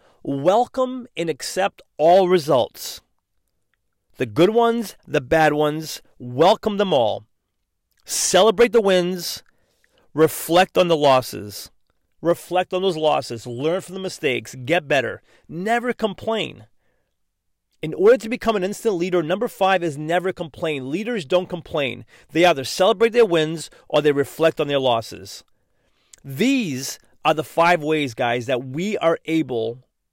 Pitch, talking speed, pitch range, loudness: 165 Hz, 135 wpm, 140-190 Hz, -20 LUFS